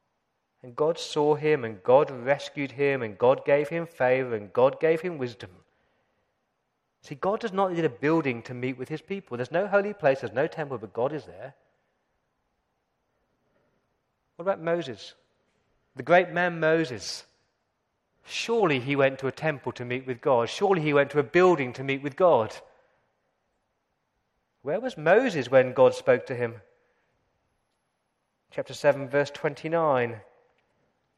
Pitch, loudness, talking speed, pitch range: 145 Hz, -26 LUFS, 150 wpm, 130-170 Hz